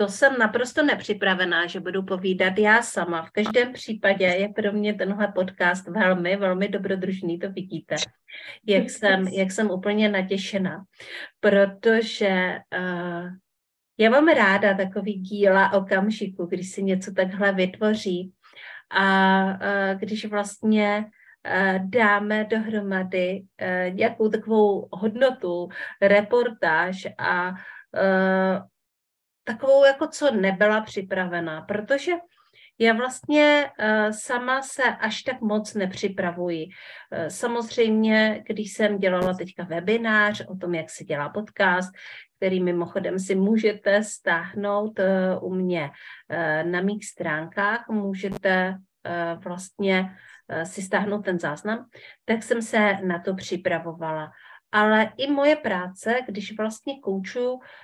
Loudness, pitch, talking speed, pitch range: -23 LUFS, 200 Hz, 115 wpm, 185-220 Hz